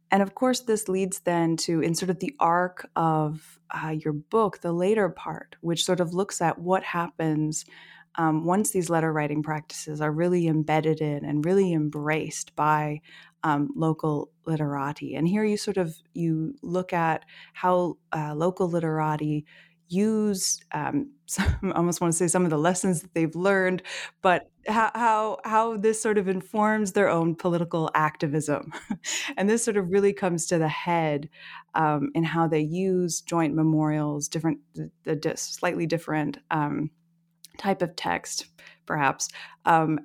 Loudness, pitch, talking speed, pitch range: -26 LUFS, 165 Hz, 160 wpm, 155-185 Hz